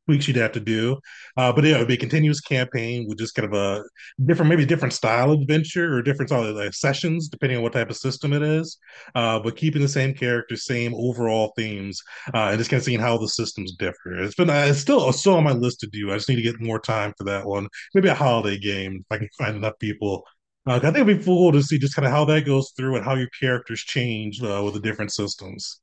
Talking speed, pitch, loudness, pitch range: 260 wpm, 125 Hz, -22 LUFS, 110-145 Hz